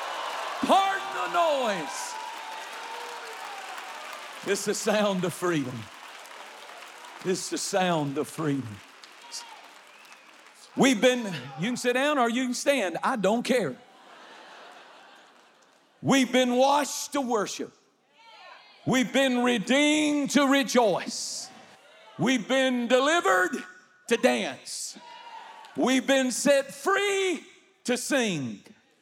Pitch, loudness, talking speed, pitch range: 255 Hz, -26 LUFS, 95 wpm, 200-290 Hz